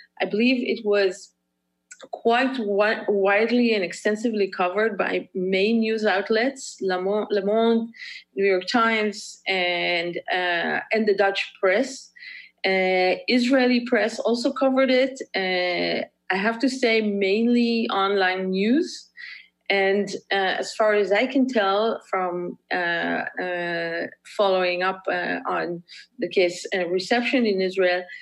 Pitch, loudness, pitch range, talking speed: 200 Hz, -22 LUFS, 185-230 Hz, 130 wpm